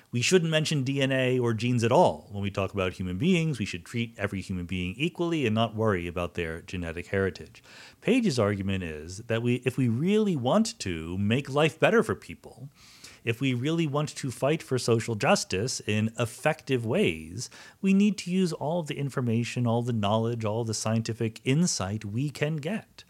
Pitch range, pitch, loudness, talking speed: 100-145 Hz, 120 Hz, -27 LUFS, 190 wpm